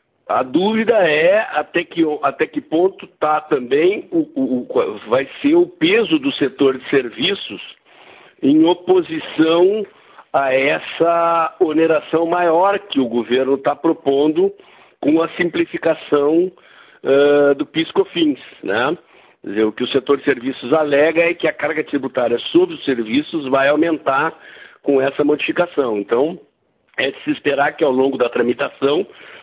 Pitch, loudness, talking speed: 165 Hz, -17 LUFS, 145 wpm